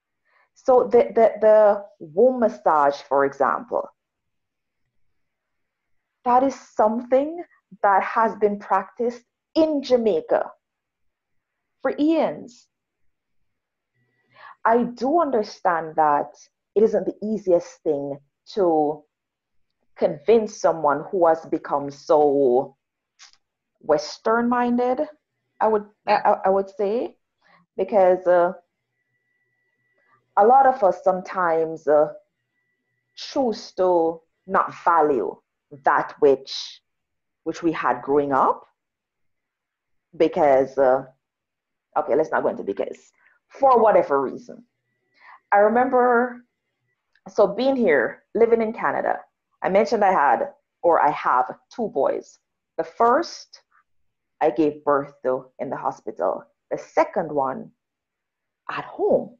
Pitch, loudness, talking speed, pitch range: 195 Hz, -21 LUFS, 105 wpm, 150-240 Hz